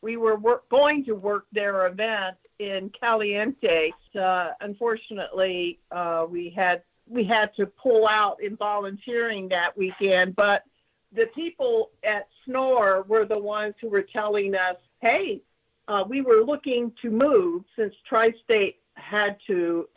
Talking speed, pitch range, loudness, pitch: 145 wpm, 195-230 Hz, -24 LUFS, 210 Hz